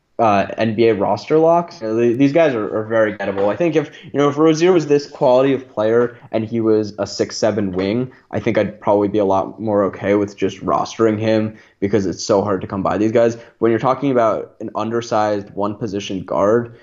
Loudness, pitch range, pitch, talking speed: -18 LUFS, 105-130 Hz, 110 Hz, 220 wpm